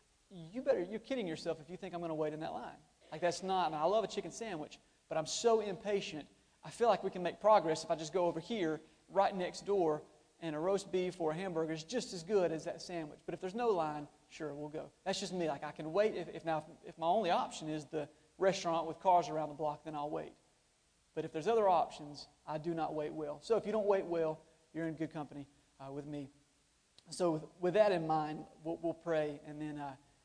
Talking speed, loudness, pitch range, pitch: 255 wpm, -37 LUFS, 155-185 Hz, 160 Hz